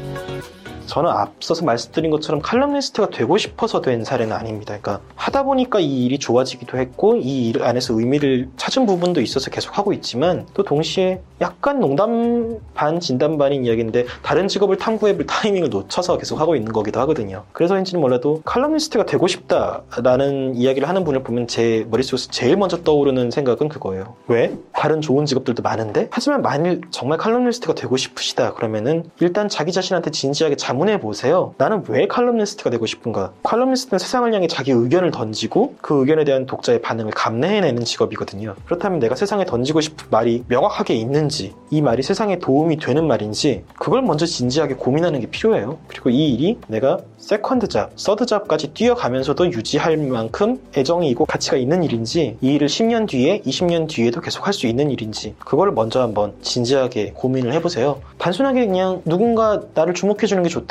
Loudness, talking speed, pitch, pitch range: -19 LUFS, 425 characters per minute, 150 Hz, 125-190 Hz